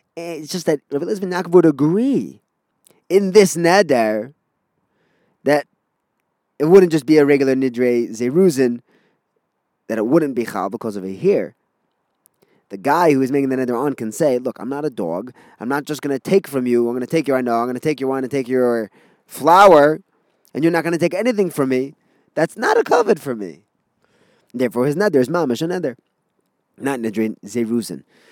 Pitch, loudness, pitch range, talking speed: 140 Hz, -17 LUFS, 120-170 Hz, 185 wpm